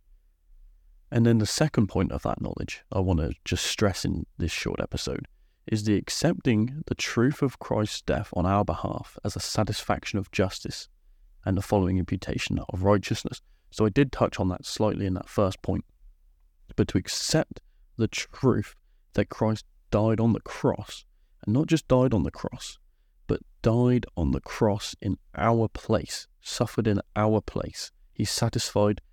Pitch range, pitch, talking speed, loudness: 85-115 Hz, 100 Hz, 170 wpm, -27 LUFS